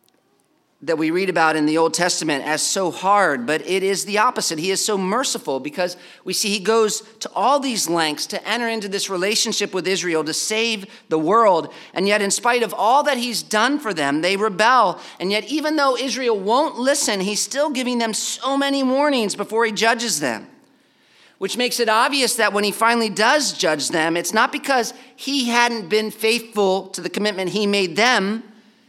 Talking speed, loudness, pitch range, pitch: 195 wpm, -19 LUFS, 185-235 Hz, 215 Hz